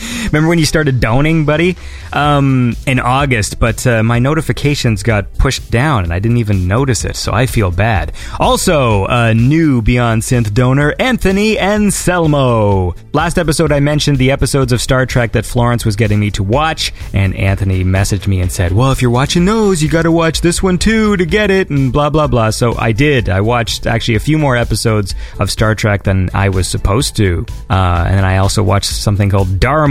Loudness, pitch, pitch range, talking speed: -13 LUFS, 120 Hz, 105-150 Hz, 205 wpm